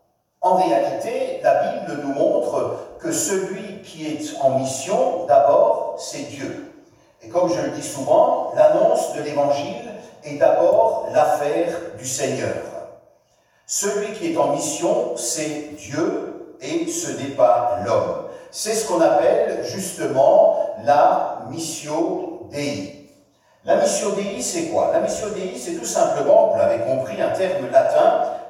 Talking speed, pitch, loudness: 140 wpm, 310 Hz, -20 LUFS